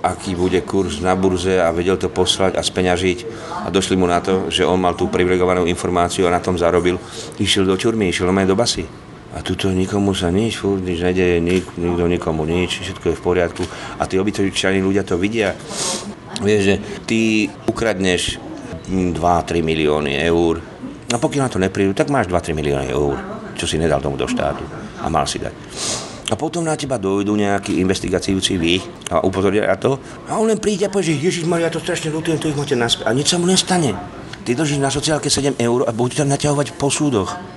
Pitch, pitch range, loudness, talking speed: 95 Hz, 90-130 Hz, -18 LUFS, 205 wpm